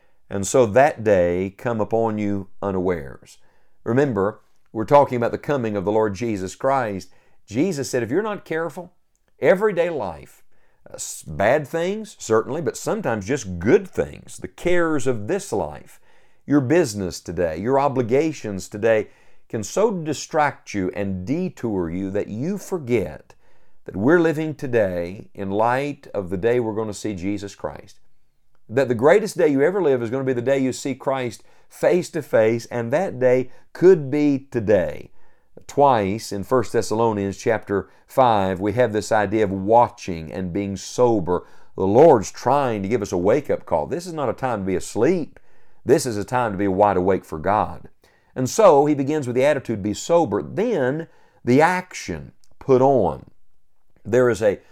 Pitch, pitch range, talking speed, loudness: 120 Hz, 100-145 Hz, 175 wpm, -21 LUFS